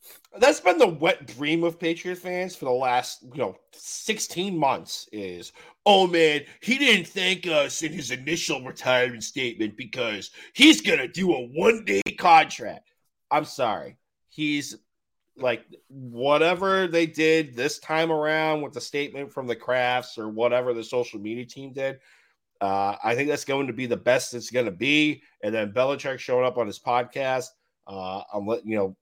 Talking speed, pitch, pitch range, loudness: 170 wpm, 135 Hz, 120-165 Hz, -24 LUFS